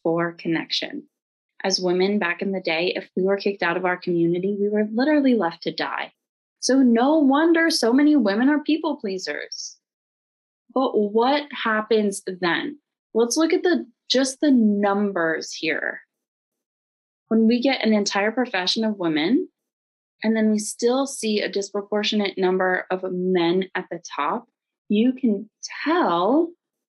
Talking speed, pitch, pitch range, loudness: 150 wpm, 215 Hz, 185-265 Hz, -22 LUFS